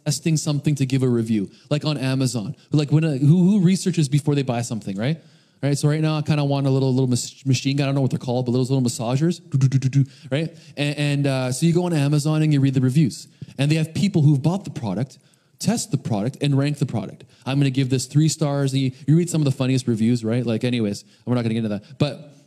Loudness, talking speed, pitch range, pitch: -21 LUFS, 265 wpm, 130-150 Hz, 140 Hz